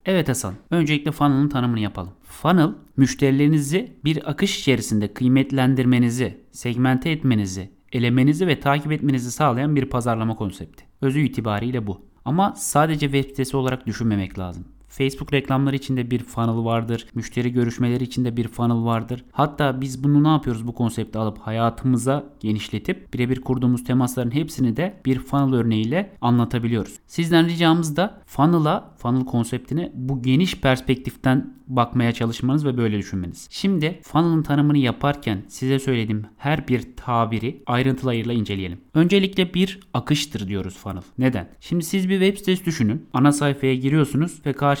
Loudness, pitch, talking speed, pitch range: -22 LUFS, 130 Hz, 140 wpm, 115-145 Hz